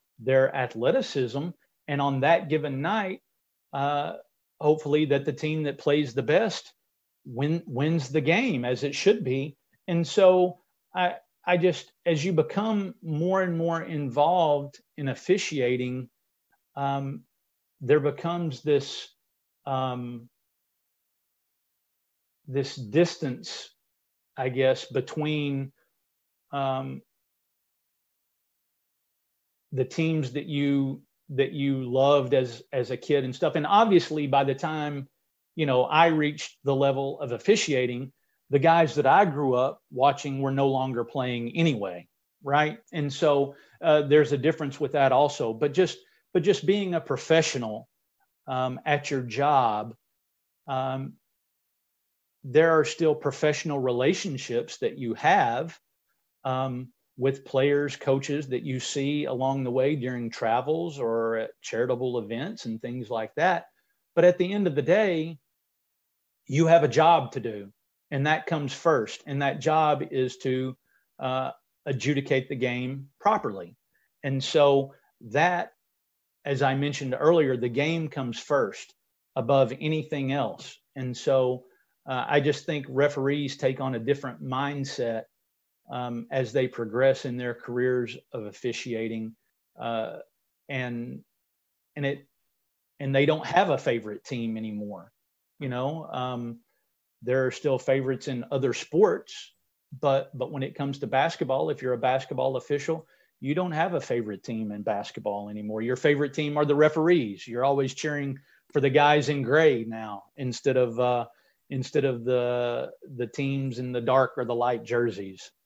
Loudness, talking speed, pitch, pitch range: -26 LUFS, 140 wpm, 140 Hz, 125-150 Hz